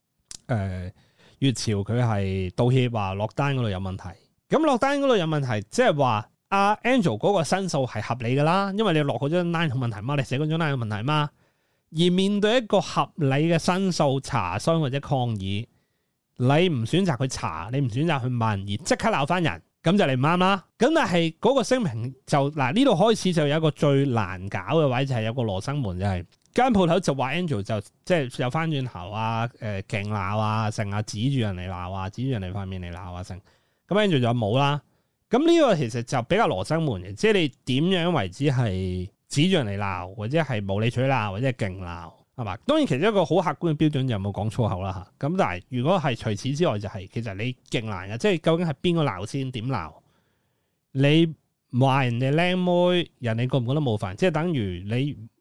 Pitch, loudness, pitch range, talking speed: 135 Hz, -24 LUFS, 110-165 Hz, 325 characters per minute